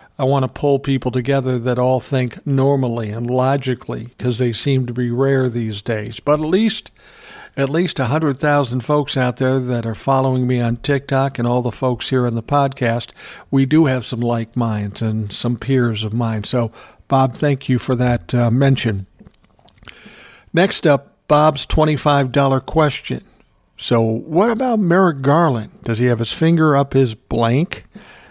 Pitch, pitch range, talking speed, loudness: 130 Hz, 120-140 Hz, 175 wpm, -18 LUFS